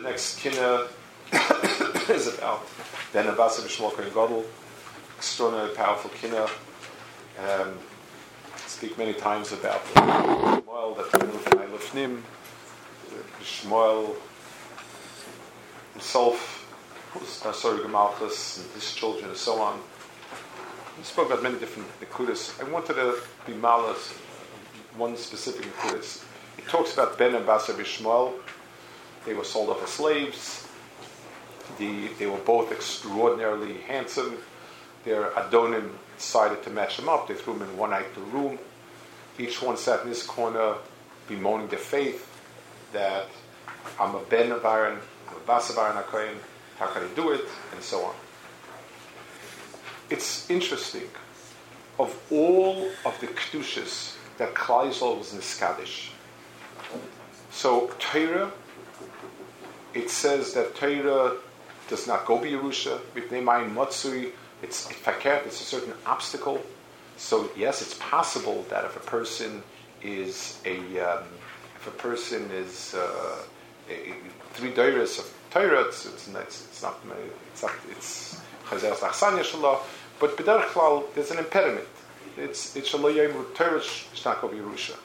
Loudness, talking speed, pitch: -27 LUFS, 130 wpm, 125 Hz